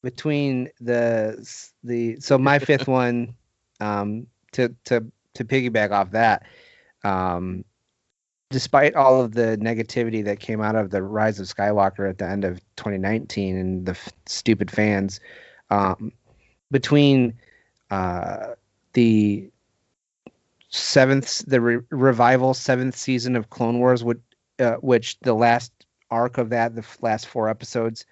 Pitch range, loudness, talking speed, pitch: 105-125 Hz, -22 LUFS, 140 wpm, 115 Hz